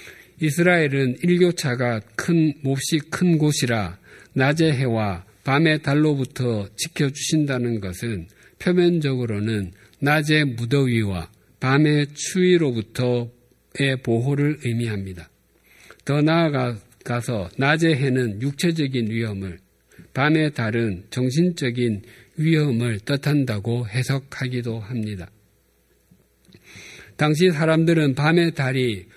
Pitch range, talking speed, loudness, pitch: 115-150 Hz, 230 characters per minute, -21 LUFS, 130 Hz